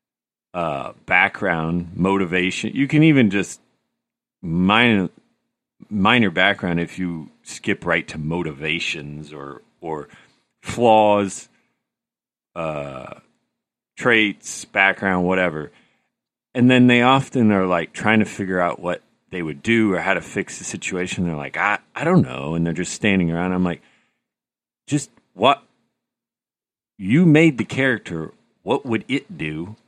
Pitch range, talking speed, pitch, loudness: 85-110 Hz, 135 wpm, 90 Hz, -19 LUFS